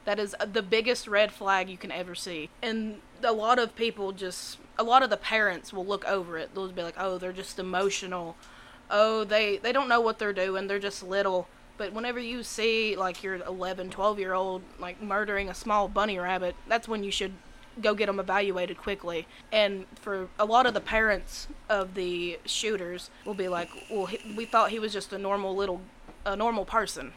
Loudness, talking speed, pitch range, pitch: -29 LUFS, 210 wpm, 185-220 Hz, 200 Hz